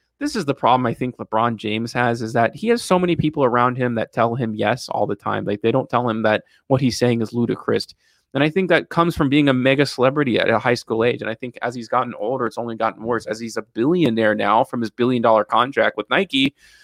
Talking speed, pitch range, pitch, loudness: 265 wpm, 110-135 Hz, 120 Hz, -20 LUFS